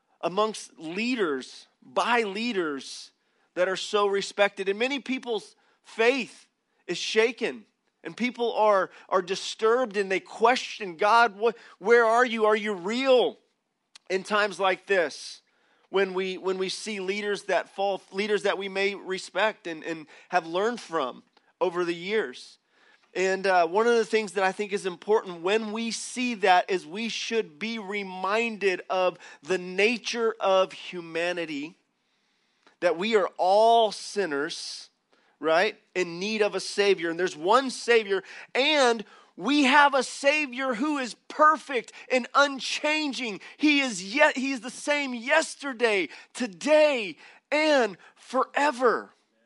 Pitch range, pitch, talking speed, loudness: 190-250 Hz, 215 Hz, 135 wpm, -26 LUFS